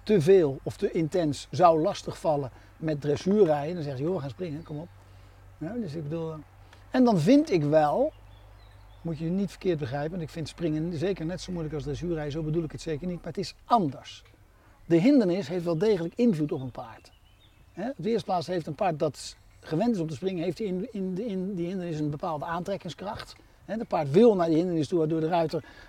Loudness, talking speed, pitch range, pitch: -27 LUFS, 220 wpm, 145-185 Hz, 165 Hz